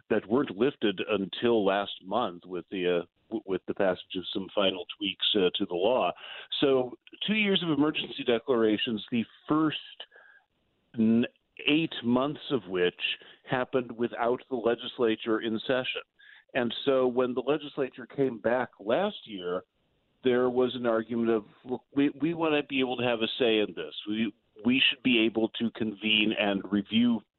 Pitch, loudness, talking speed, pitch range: 120 Hz, -28 LUFS, 165 wpm, 110-135 Hz